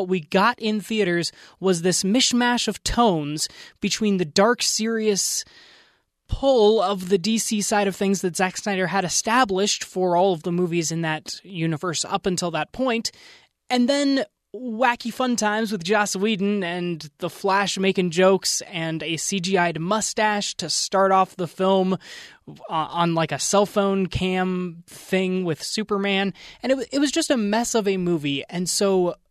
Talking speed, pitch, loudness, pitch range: 165 wpm, 195 Hz, -22 LUFS, 180-215 Hz